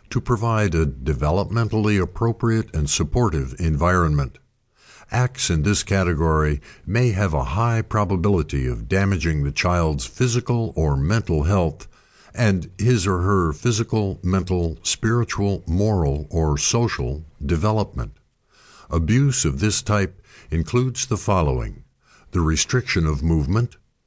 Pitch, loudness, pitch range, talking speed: 95 Hz, -21 LUFS, 80-110 Hz, 115 wpm